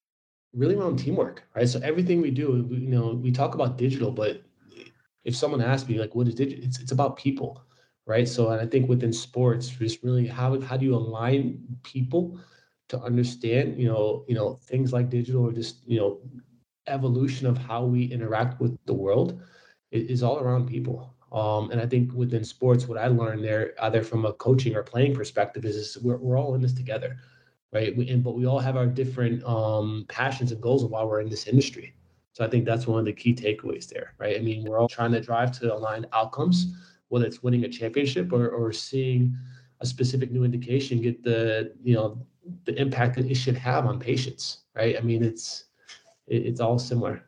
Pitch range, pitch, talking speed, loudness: 115-130 Hz, 125 Hz, 210 wpm, -26 LUFS